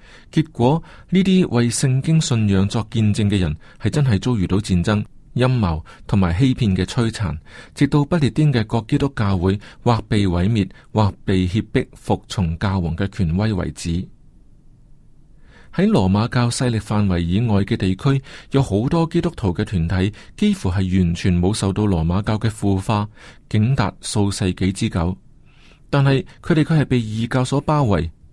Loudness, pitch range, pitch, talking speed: -19 LUFS, 95-130 Hz, 110 Hz, 240 characters per minute